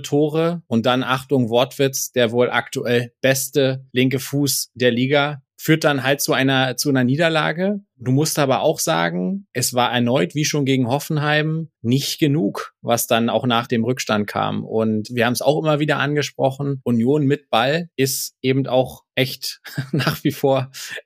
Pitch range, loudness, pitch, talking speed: 125-145 Hz, -19 LUFS, 135 Hz, 170 wpm